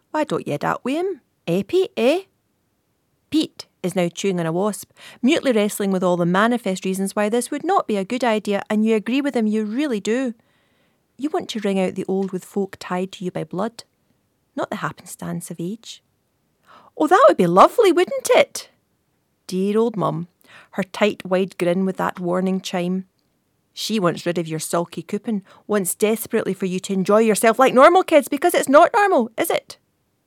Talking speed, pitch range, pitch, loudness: 195 wpm, 185-255 Hz, 210 Hz, -20 LUFS